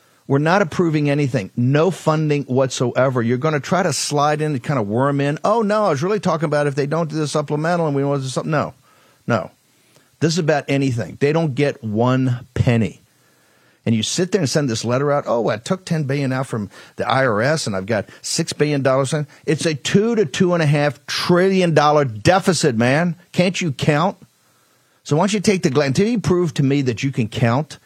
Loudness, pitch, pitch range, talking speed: -19 LUFS, 145 Hz, 130-170 Hz, 225 wpm